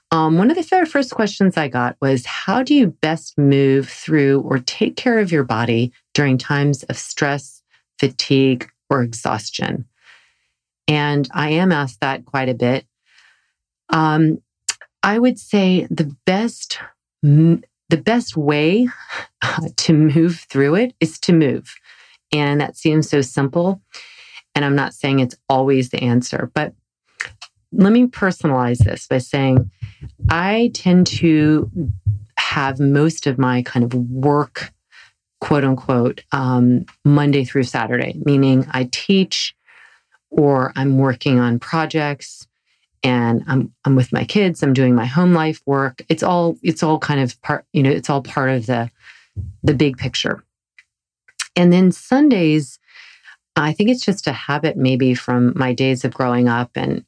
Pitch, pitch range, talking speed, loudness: 145 Hz, 130-165 Hz, 150 wpm, -17 LUFS